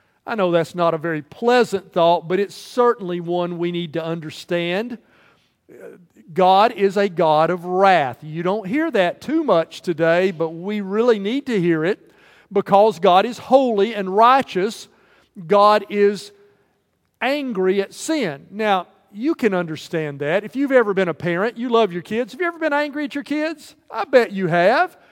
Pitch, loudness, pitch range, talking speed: 200 Hz, -19 LUFS, 175-240 Hz, 175 wpm